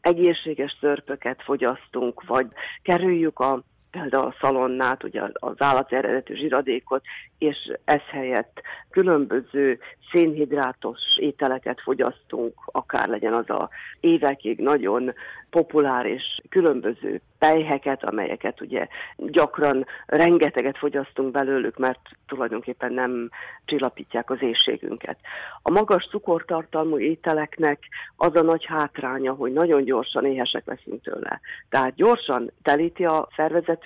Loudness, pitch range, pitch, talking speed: -23 LUFS, 130-165 Hz, 145 Hz, 110 wpm